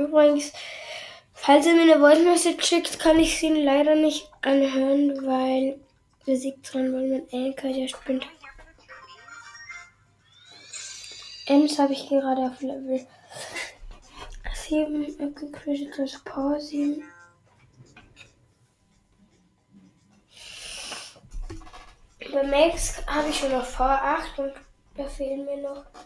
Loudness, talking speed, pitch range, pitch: -23 LUFS, 95 wpm, 265-300 Hz, 280 Hz